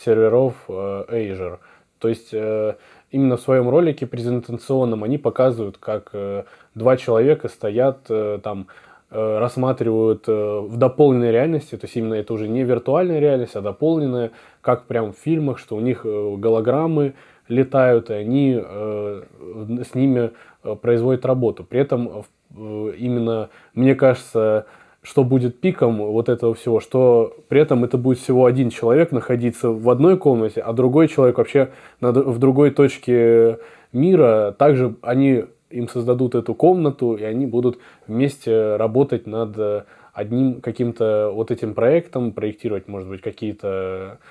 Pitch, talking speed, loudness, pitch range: 120 Hz, 130 wpm, -19 LUFS, 110-130 Hz